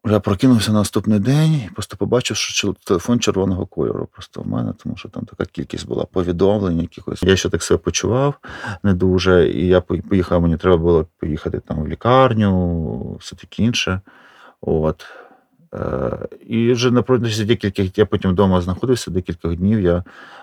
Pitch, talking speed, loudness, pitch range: 100 Hz, 165 wpm, -18 LUFS, 90-110 Hz